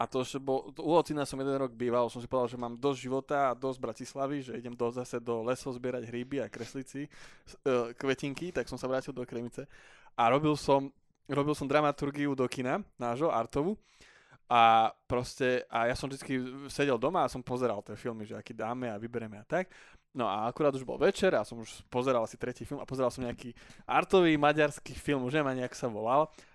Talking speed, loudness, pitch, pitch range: 210 wpm, -32 LUFS, 130 Hz, 120-140 Hz